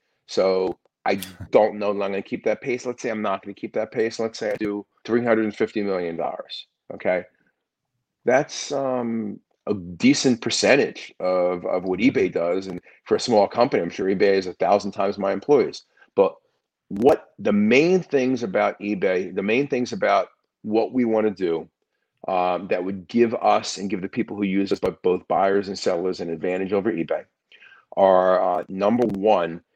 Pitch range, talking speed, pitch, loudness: 95-115 Hz, 185 wpm, 100 Hz, -22 LUFS